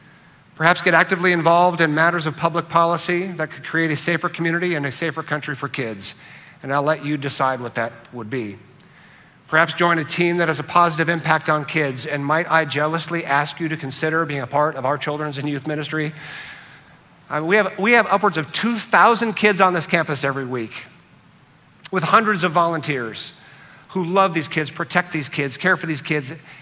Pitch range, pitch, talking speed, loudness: 145-175 Hz, 160 Hz, 200 wpm, -19 LUFS